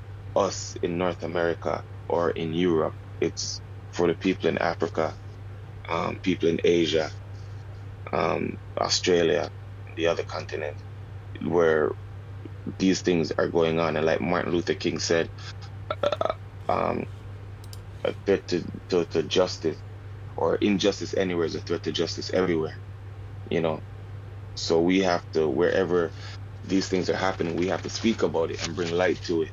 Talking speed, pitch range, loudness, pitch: 150 wpm, 85-100 Hz, -26 LUFS, 100 Hz